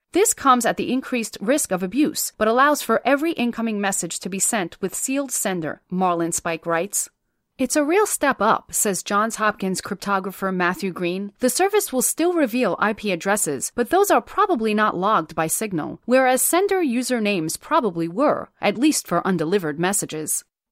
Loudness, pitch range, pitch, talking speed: -21 LUFS, 185-260 Hz, 210 Hz, 170 wpm